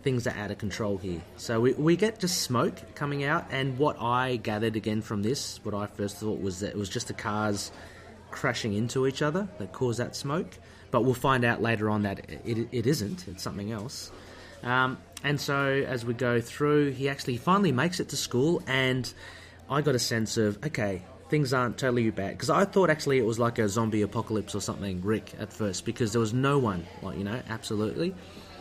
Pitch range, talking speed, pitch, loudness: 100-130 Hz, 215 wpm, 115 Hz, -29 LUFS